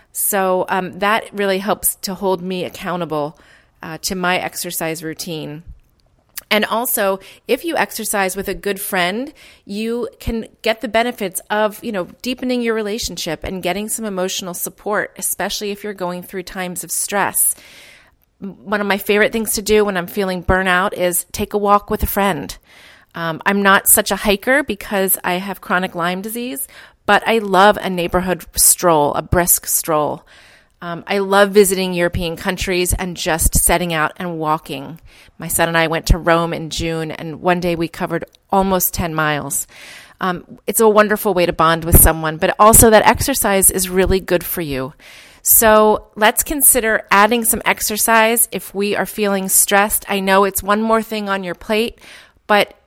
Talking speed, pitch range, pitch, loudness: 175 wpm, 175-210 Hz, 190 Hz, -16 LUFS